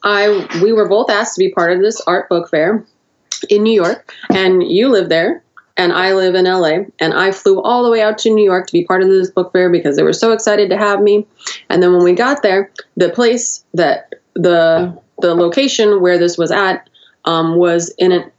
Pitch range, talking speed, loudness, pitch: 175-210 Hz, 230 wpm, -13 LUFS, 190 Hz